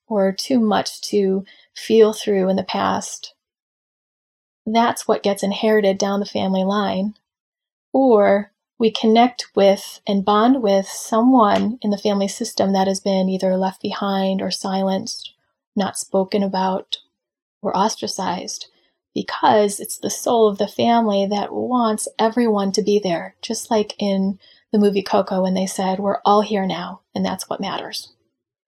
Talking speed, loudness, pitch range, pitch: 150 wpm, -19 LUFS, 195-220 Hz, 205 Hz